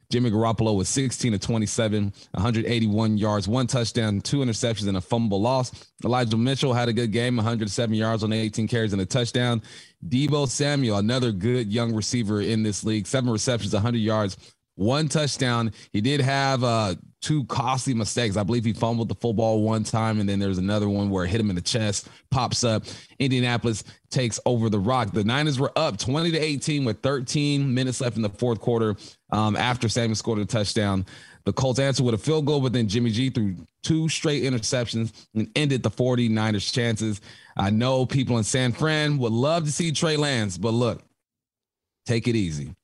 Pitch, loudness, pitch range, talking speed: 115 Hz, -24 LUFS, 110-130 Hz, 190 wpm